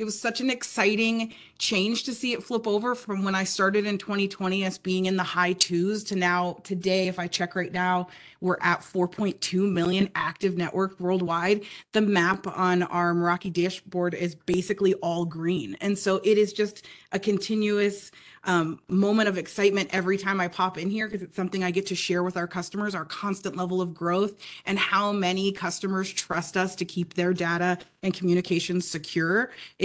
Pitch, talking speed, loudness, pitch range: 190 Hz, 185 wpm, -26 LUFS, 180-200 Hz